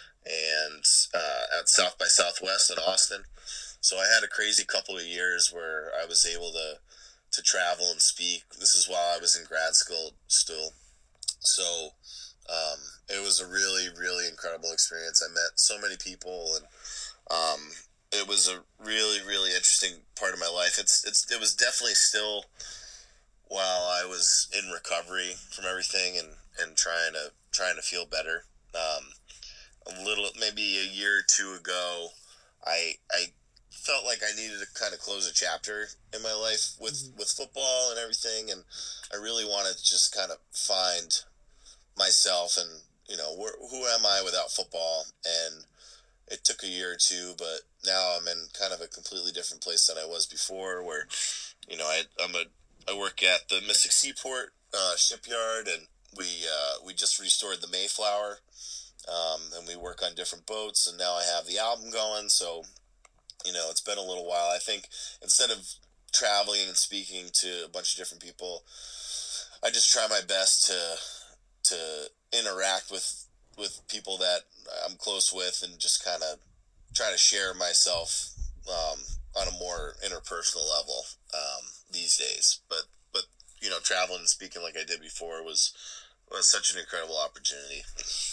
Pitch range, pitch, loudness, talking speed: 85-105 Hz, 90 Hz, -27 LUFS, 175 wpm